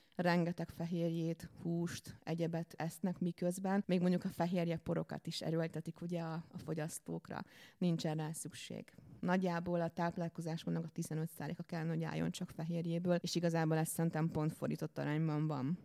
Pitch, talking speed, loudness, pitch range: 165 Hz, 140 wpm, -39 LUFS, 160-175 Hz